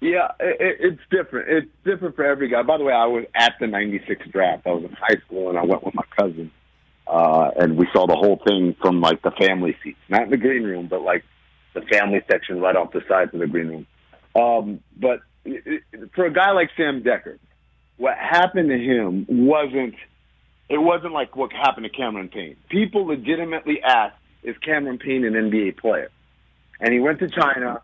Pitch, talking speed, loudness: 125 Hz, 205 wpm, -20 LUFS